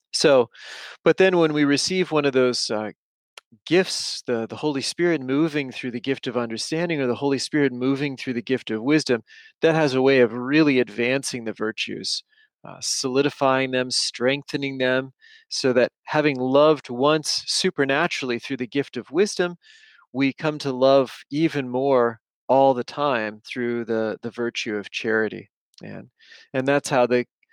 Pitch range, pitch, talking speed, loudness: 120-150 Hz, 135 Hz, 165 wpm, -22 LUFS